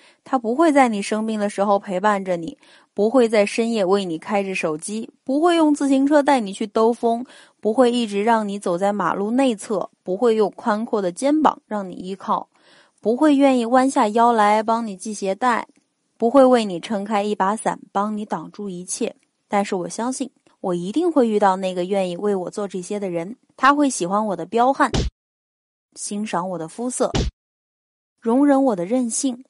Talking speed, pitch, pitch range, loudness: 265 characters per minute, 220 Hz, 200-260 Hz, -20 LUFS